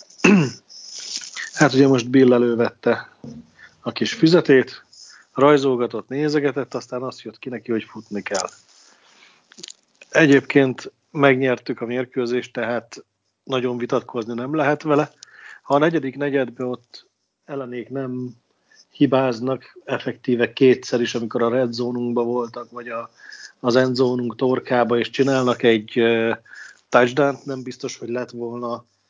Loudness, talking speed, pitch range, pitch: -20 LUFS, 120 wpm, 120-135 Hz, 125 Hz